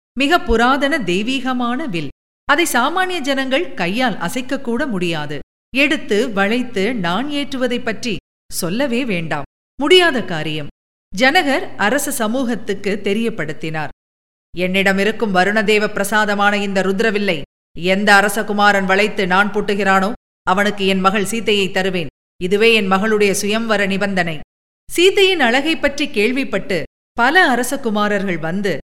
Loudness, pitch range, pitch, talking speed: -16 LUFS, 190-255 Hz, 210 Hz, 105 wpm